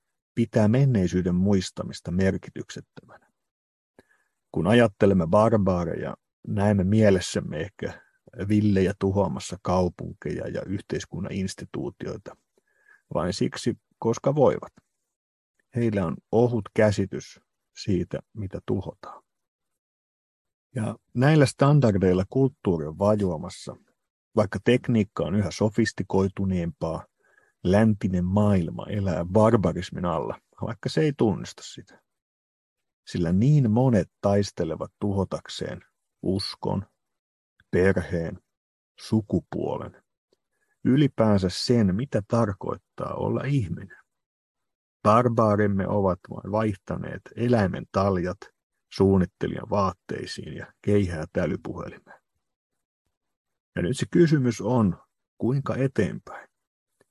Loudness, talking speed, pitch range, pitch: -25 LUFS, 85 wpm, 95-115 Hz, 100 Hz